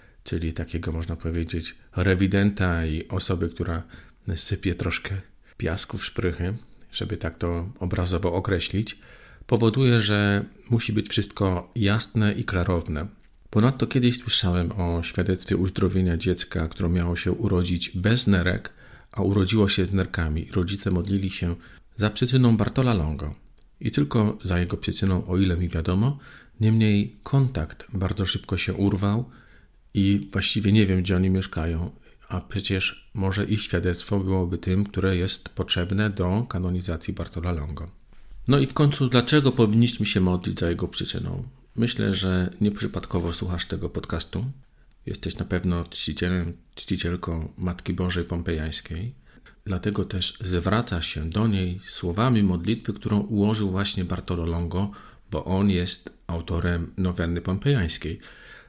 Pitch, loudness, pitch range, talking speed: 95 Hz, -25 LUFS, 85-105 Hz, 135 wpm